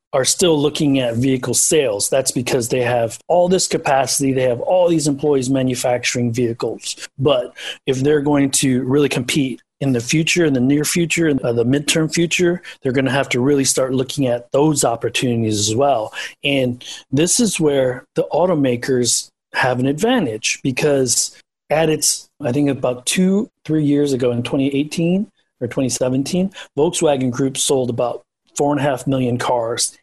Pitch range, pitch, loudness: 125-155 Hz, 135 Hz, -17 LUFS